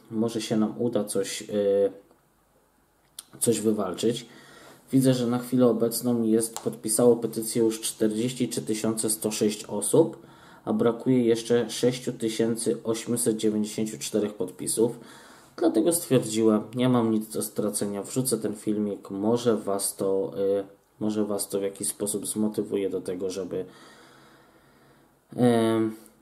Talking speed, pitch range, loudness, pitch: 115 wpm, 105-120 Hz, -26 LUFS, 110 Hz